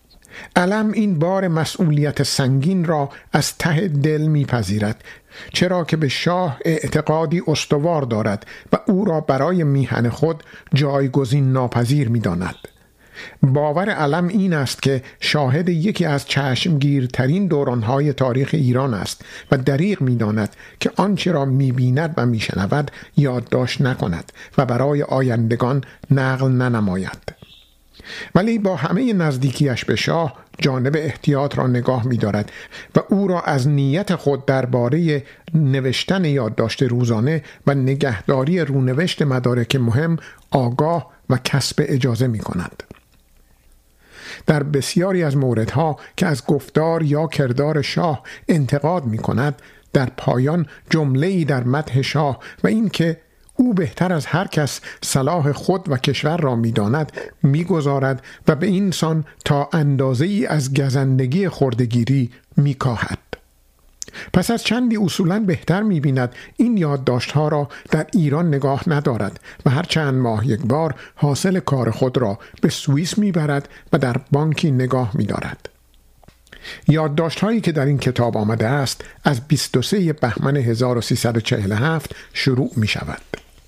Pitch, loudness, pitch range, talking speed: 140 Hz, -19 LUFS, 125-165 Hz, 130 wpm